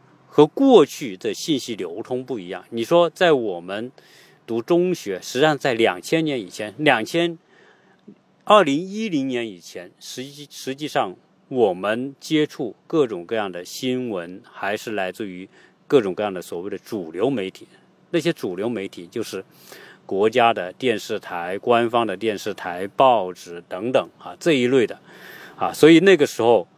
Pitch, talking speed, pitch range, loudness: 135 Hz, 240 characters per minute, 115-170 Hz, -21 LUFS